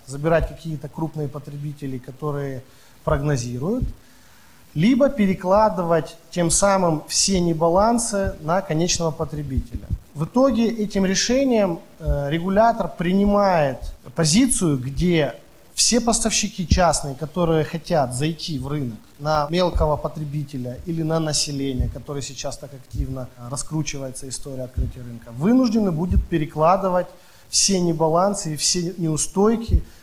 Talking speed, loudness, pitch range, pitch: 105 wpm, -21 LUFS, 145-185 Hz, 160 Hz